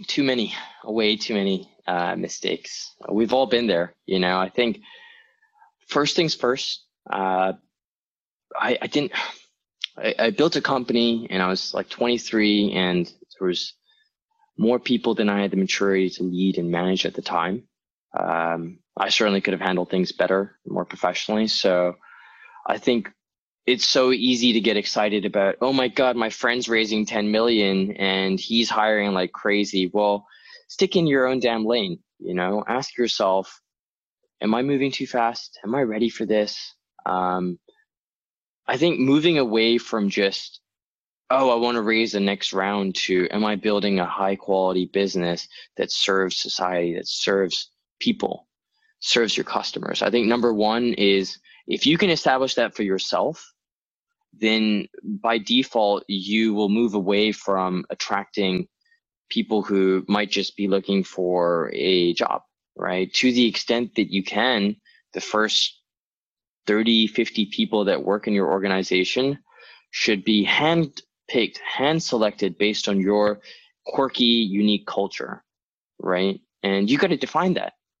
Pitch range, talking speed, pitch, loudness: 95-120 Hz, 155 wpm, 105 Hz, -22 LUFS